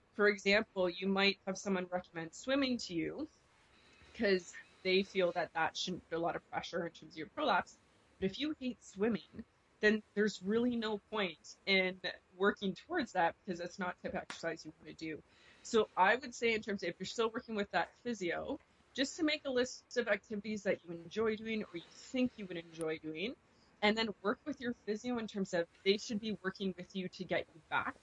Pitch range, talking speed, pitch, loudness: 180-225 Hz, 220 wpm, 200 Hz, -37 LUFS